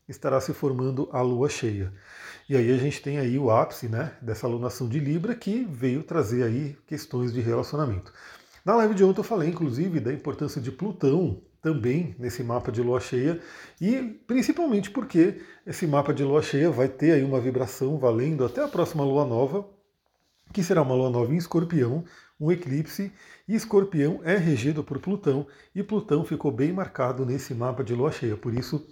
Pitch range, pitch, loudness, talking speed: 130-175 Hz, 145 Hz, -26 LUFS, 185 wpm